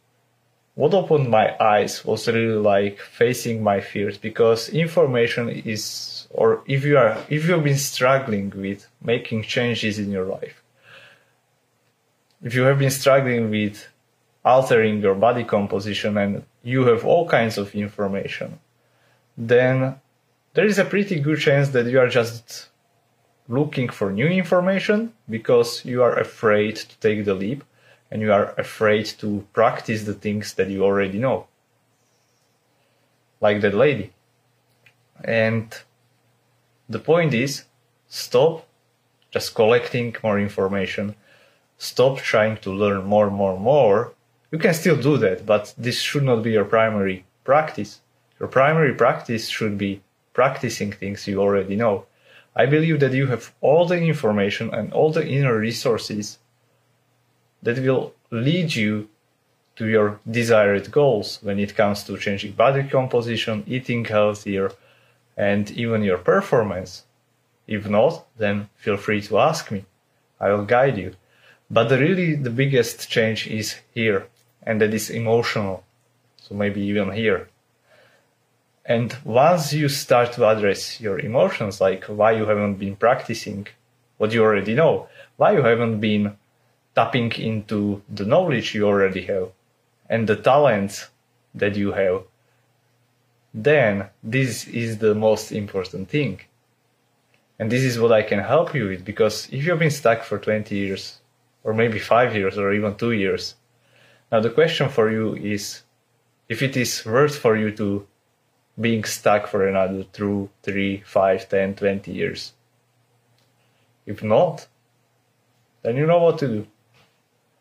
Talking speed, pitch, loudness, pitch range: 145 wpm, 115 Hz, -21 LUFS, 105-125 Hz